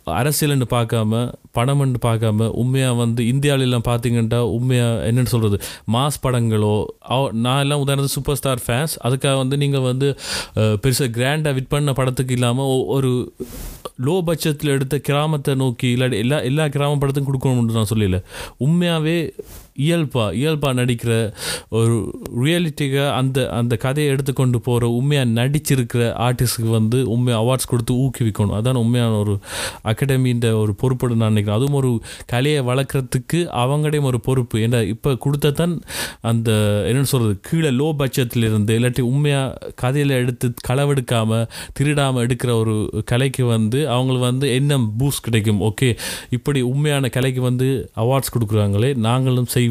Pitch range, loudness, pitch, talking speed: 115-140 Hz, -19 LUFS, 125 Hz, 135 wpm